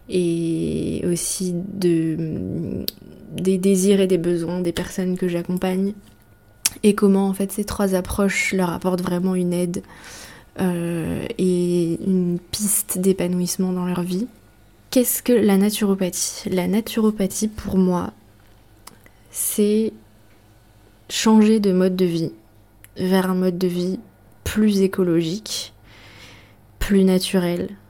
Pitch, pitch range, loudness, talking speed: 180 Hz, 165-195 Hz, -21 LUFS, 120 wpm